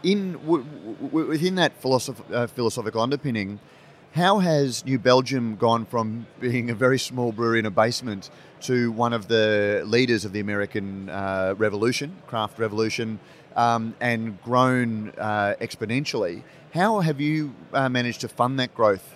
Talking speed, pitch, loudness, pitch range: 145 wpm, 120 Hz, -24 LUFS, 110-135 Hz